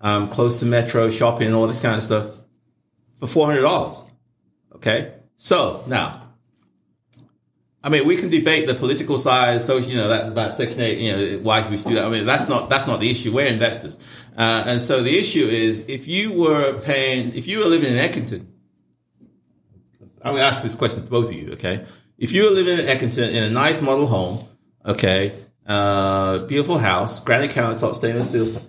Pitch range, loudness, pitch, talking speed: 105-130 Hz, -19 LUFS, 115 Hz, 195 wpm